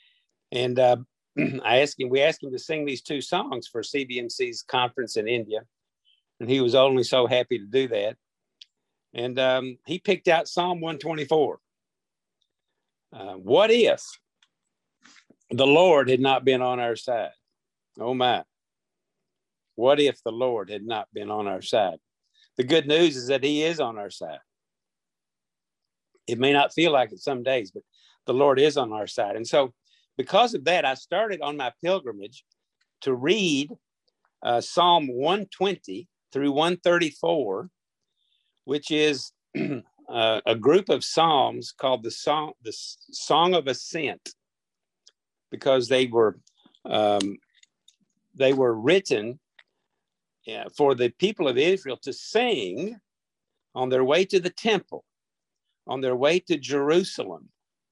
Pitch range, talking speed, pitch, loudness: 125-180 Hz, 145 wpm, 140 Hz, -24 LUFS